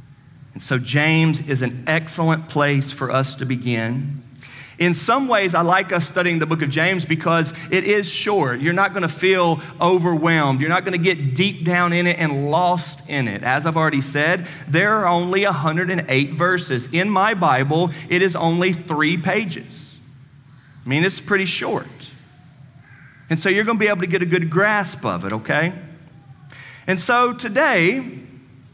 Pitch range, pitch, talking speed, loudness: 140-180 Hz, 160 Hz, 170 wpm, -19 LUFS